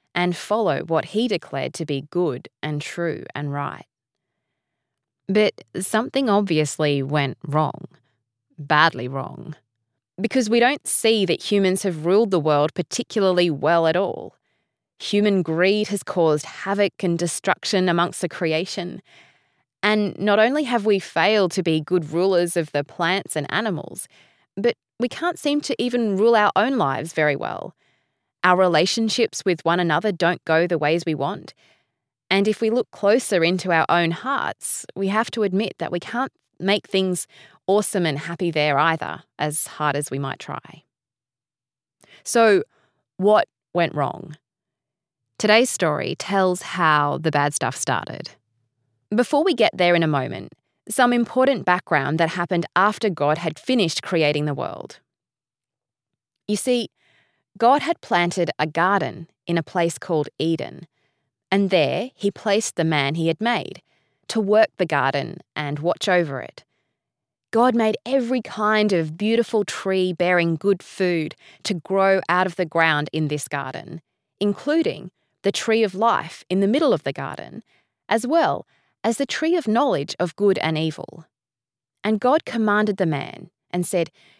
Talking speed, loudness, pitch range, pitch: 155 wpm, -21 LUFS, 150-205 Hz, 175 Hz